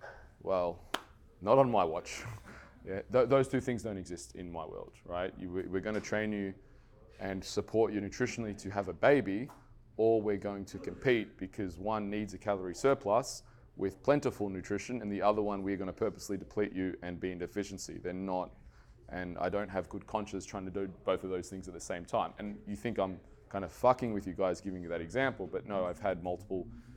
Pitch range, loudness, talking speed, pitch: 95-110 Hz, -35 LUFS, 215 wpm, 100 Hz